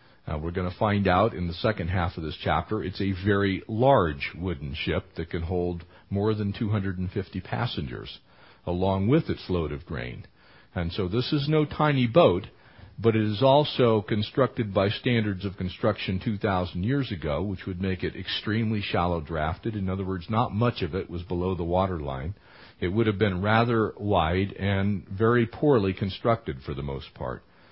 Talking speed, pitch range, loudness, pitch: 180 wpm, 90-110 Hz, -26 LUFS, 100 Hz